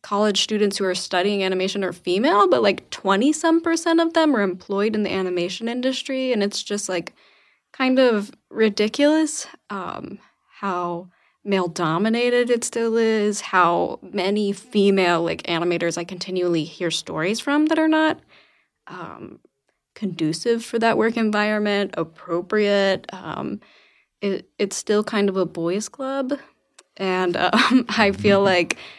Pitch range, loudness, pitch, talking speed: 185-240 Hz, -21 LUFS, 205 Hz, 145 wpm